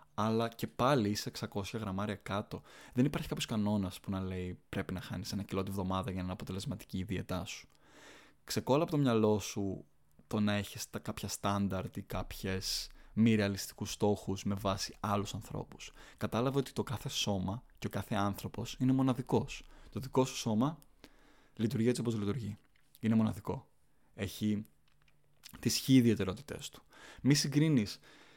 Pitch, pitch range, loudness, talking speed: 105 Hz, 95-120 Hz, -35 LUFS, 160 wpm